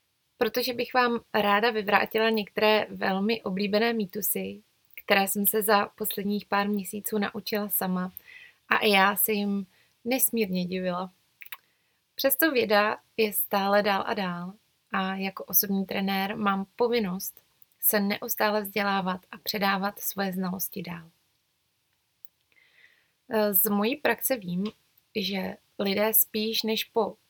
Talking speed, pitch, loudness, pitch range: 120 wpm, 205 Hz, -26 LUFS, 195-220 Hz